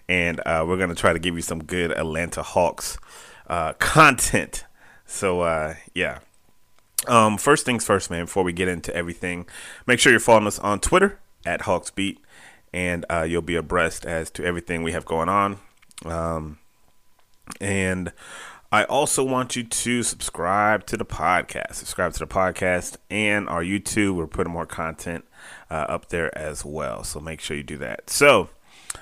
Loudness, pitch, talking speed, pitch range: -22 LUFS, 90 Hz, 170 wpm, 85-100 Hz